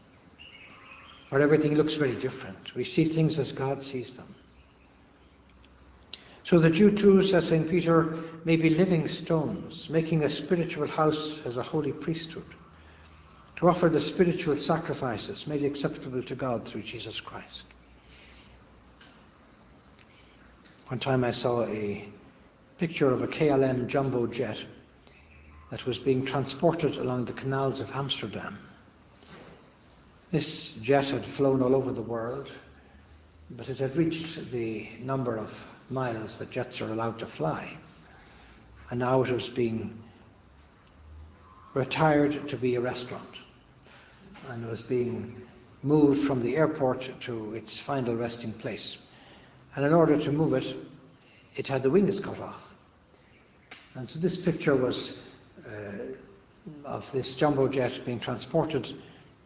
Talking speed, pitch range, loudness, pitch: 130 wpm, 115-150 Hz, -28 LUFS, 130 Hz